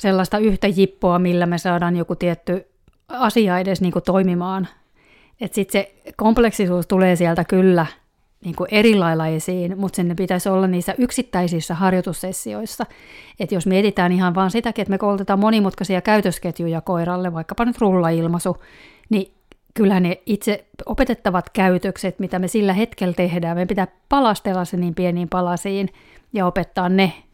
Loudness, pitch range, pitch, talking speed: -19 LUFS, 180-200 Hz, 185 Hz, 145 wpm